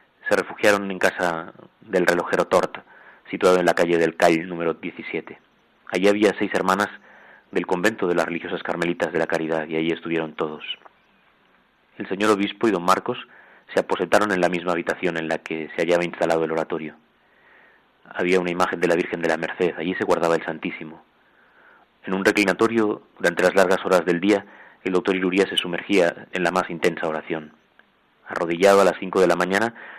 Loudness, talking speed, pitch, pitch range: -22 LUFS, 185 wpm, 85 Hz, 80-95 Hz